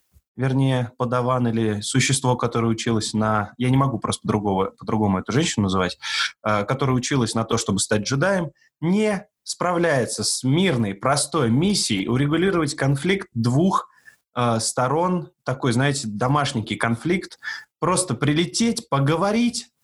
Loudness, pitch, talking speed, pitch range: -22 LUFS, 130 Hz, 125 wpm, 115-170 Hz